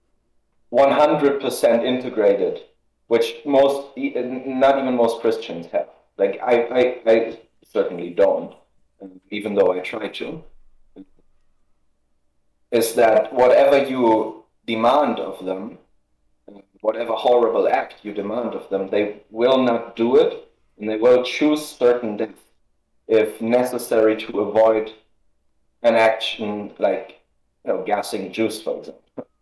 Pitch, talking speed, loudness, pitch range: 115 Hz, 120 wpm, -20 LUFS, 105-130 Hz